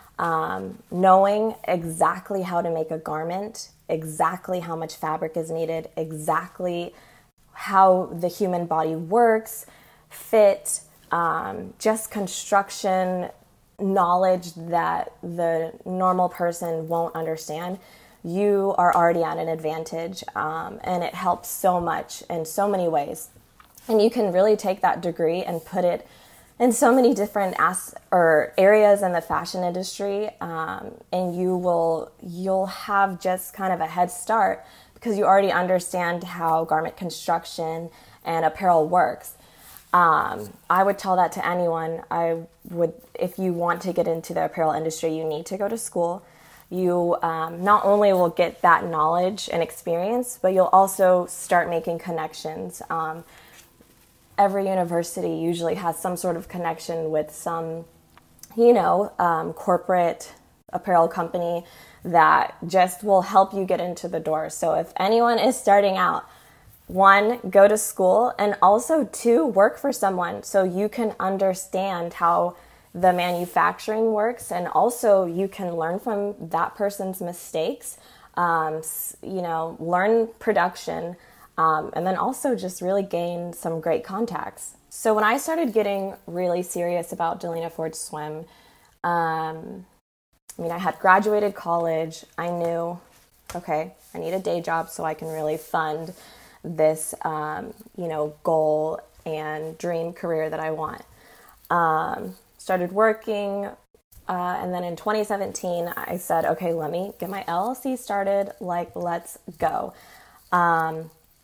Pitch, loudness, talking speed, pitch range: 175 Hz, -23 LUFS, 145 wpm, 165-195 Hz